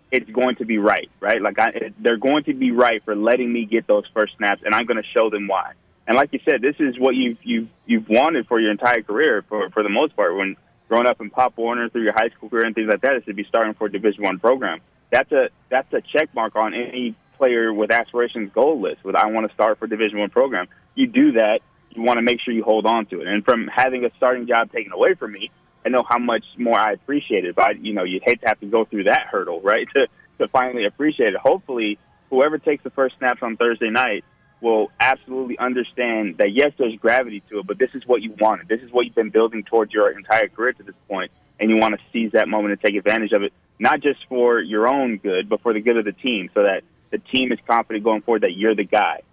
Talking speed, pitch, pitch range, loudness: 265 wpm, 115 Hz, 110-125 Hz, -20 LUFS